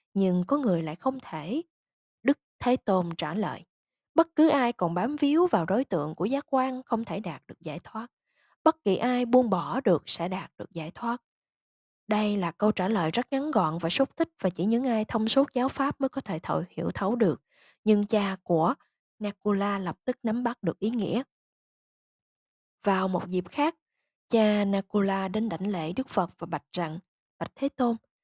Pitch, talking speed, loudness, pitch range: 215 Hz, 200 wpm, -27 LUFS, 180-255 Hz